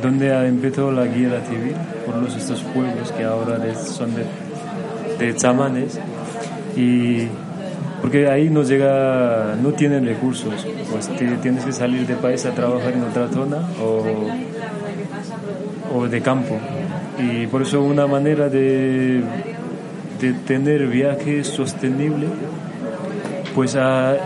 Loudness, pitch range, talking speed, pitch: -20 LUFS, 125-145 Hz, 125 wpm, 130 Hz